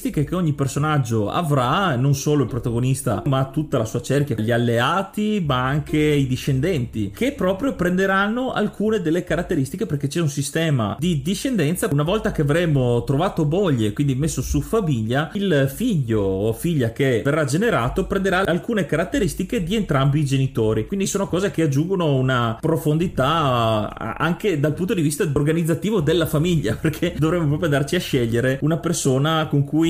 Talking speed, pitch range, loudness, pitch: 160 wpm, 135-175 Hz, -21 LUFS, 150 Hz